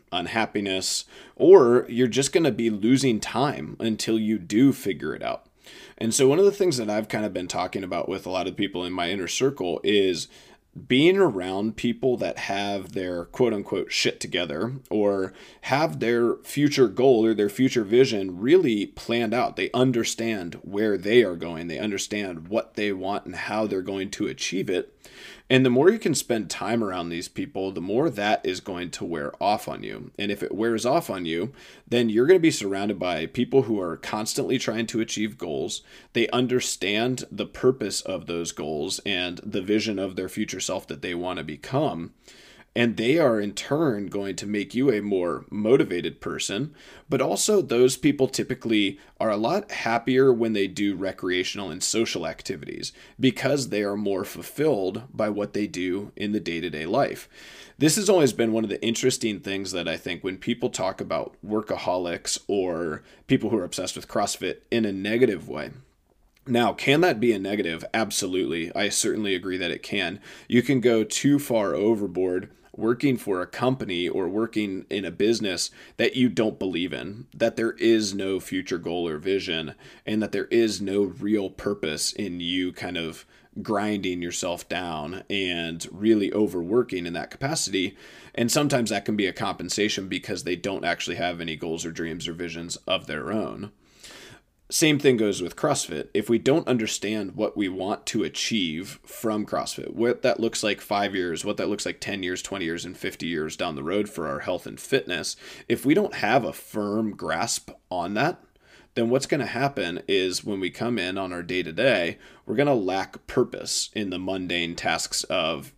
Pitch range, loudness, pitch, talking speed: 95-120 Hz, -25 LUFS, 105 Hz, 190 wpm